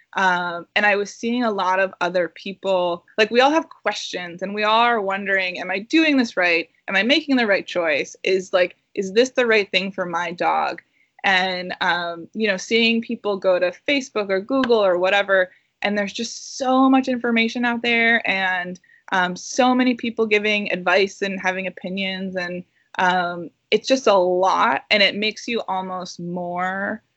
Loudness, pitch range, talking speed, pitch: -20 LUFS, 185-230 Hz, 185 wpm, 195 Hz